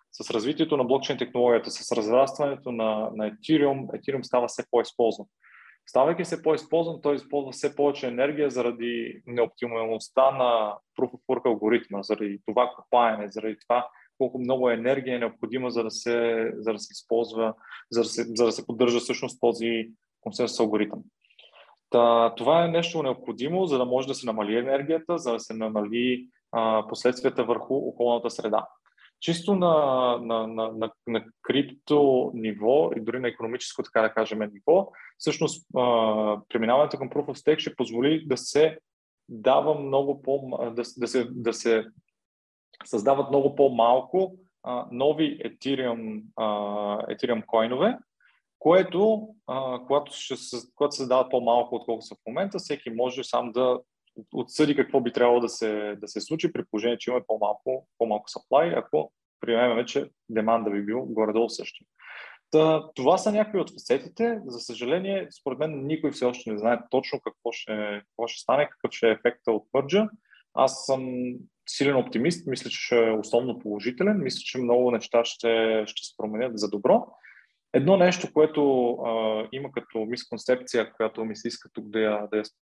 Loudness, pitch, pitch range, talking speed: -26 LUFS, 120 Hz, 115-140 Hz, 165 wpm